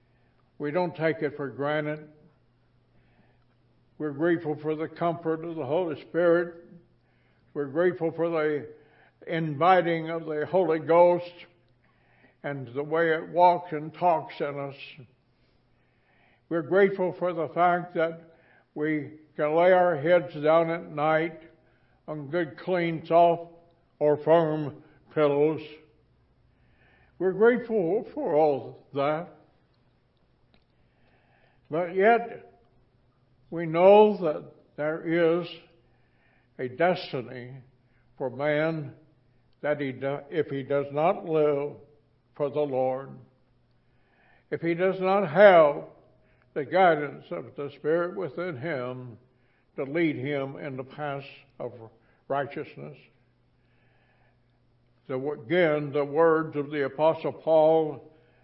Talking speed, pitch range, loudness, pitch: 110 wpm, 130-170 Hz, -26 LUFS, 150 Hz